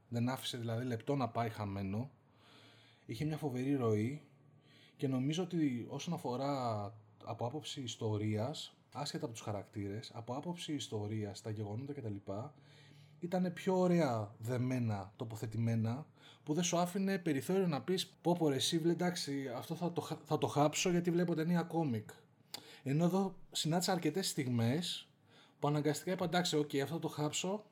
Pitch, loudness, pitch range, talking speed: 145 Hz, -37 LUFS, 115-165 Hz, 145 wpm